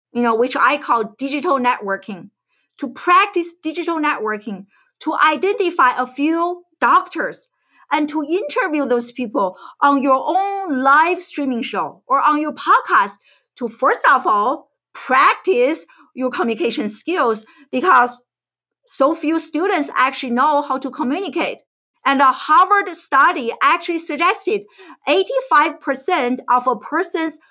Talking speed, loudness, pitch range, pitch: 125 wpm, -17 LUFS, 255-345 Hz, 300 Hz